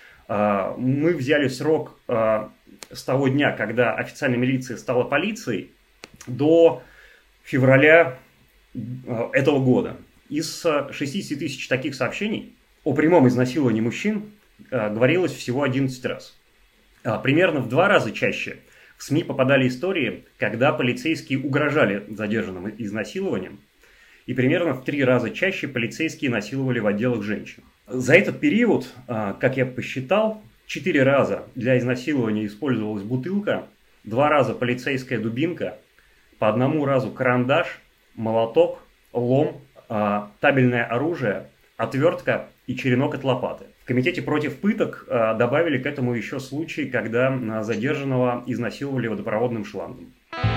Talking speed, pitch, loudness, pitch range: 115 wpm, 130 Hz, -22 LUFS, 120-145 Hz